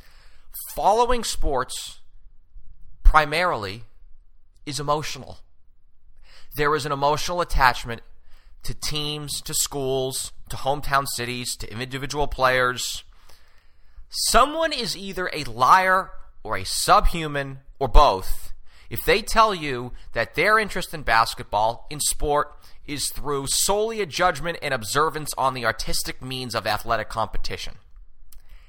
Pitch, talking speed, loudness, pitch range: 125 Hz, 115 wpm, -23 LUFS, 95-150 Hz